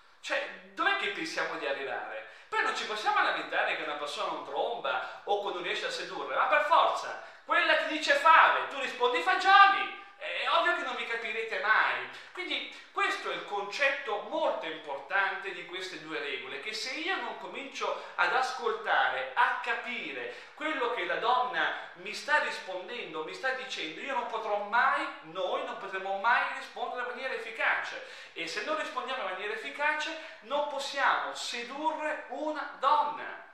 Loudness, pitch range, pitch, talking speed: -30 LUFS, 225-315 Hz, 280 Hz, 165 wpm